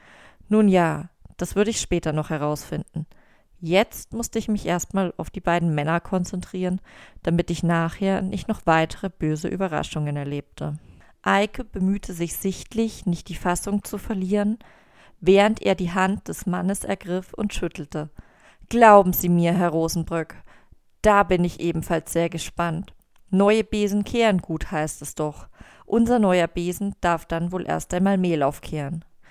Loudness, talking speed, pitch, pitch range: -23 LUFS, 150 wpm, 180 Hz, 165-200 Hz